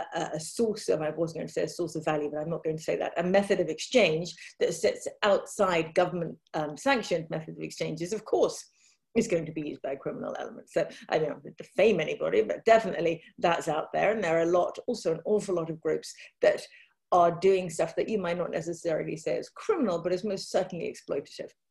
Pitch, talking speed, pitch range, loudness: 175 Hz, 225 wpm, 160-220 Hz, -29 LUFS